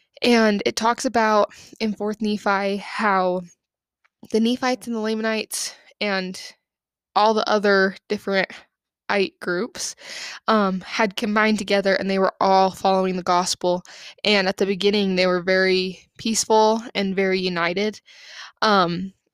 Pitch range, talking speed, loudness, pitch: 190-220 Hz, 135 wpm, -21 LUFS, 200 Hz